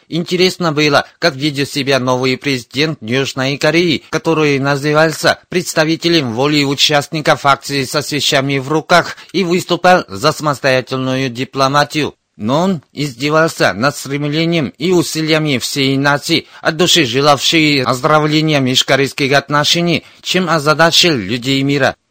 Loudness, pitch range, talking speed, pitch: -13 LUFS, 135-160 Hz, 115 wpm, 145 Hz